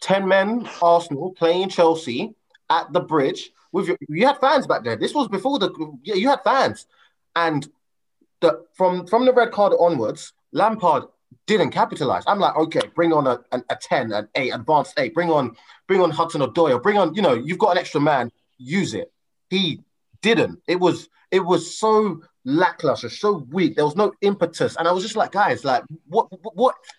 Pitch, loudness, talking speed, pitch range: 180 Hz, -20 LUFS, 195 wpm, 165-210 Hz